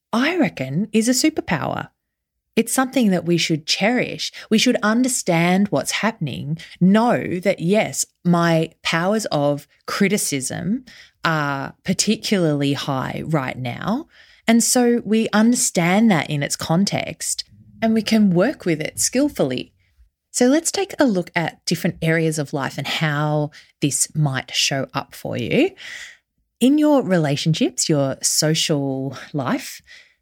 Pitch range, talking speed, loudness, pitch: 150-230 Hz, 135 wpm, -20 LUFS, 180 Hz